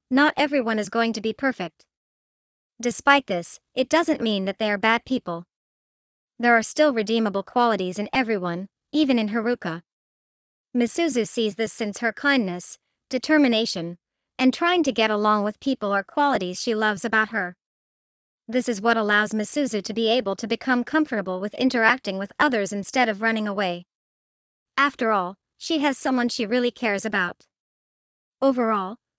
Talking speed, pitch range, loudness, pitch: 155 wpm, 205-255 Hz, -23 LUFS, 225 Hz